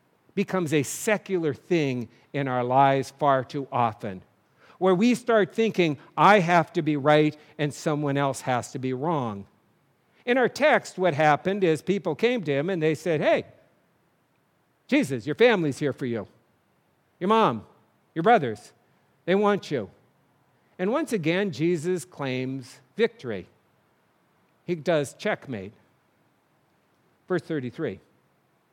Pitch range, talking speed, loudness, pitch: 135-185 Hz, 135 wpm, -25 LUFS, 155 Hz